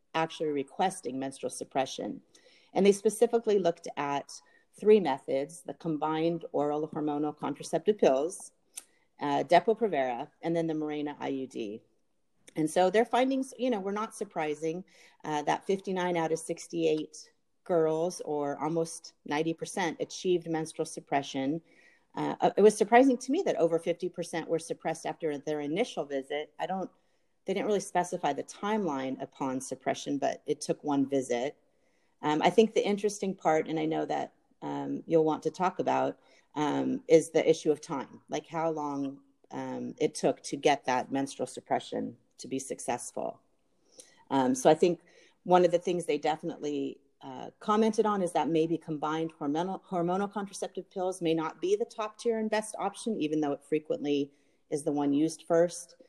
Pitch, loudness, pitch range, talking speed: 160 Hz, -30 LUFS, 150-190 Hz, 165 wpm